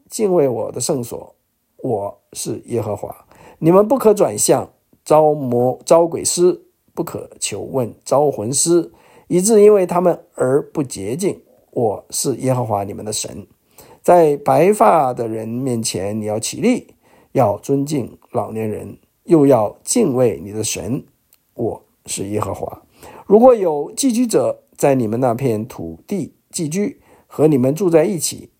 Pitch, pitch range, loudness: 145 Hz, 115-175 Hz, -17 LUFS